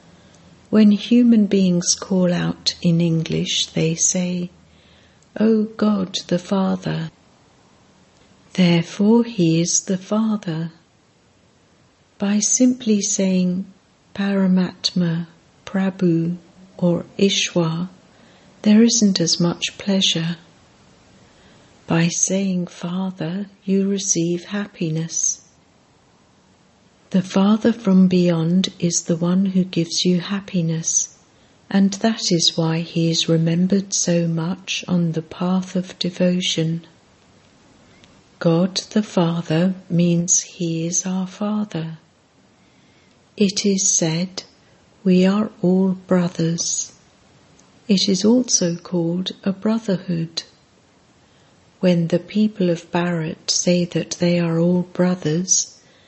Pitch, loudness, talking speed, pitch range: 180 Hz, -19 LUFS, 100 wpm, 170-195 Hz